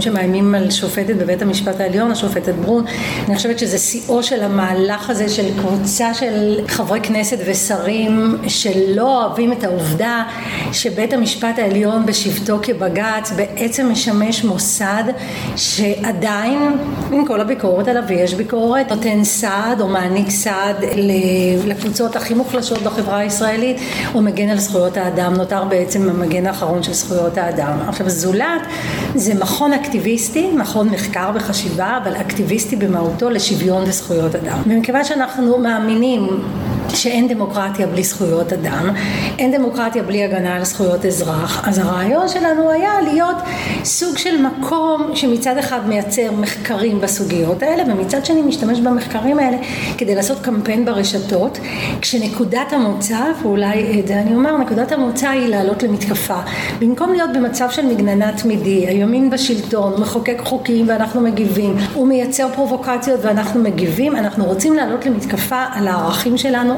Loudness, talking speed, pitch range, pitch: -16 LUFS, 135 wpm, 195-245 Hz, 215 Hz